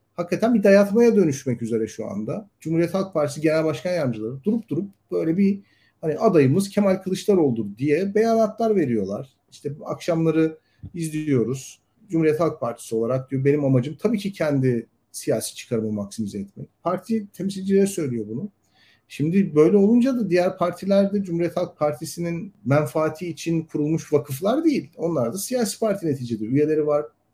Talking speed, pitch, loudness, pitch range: 150 wpm, 160 Hz, -22 LUFS, 135-195 Hz